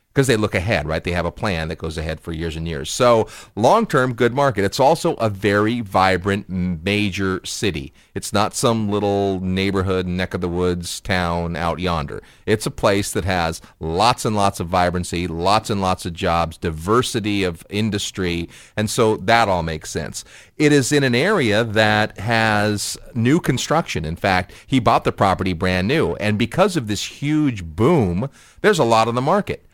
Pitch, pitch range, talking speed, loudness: 100 Hz, 90-115 Hz, 190 wpm, -19 LUFS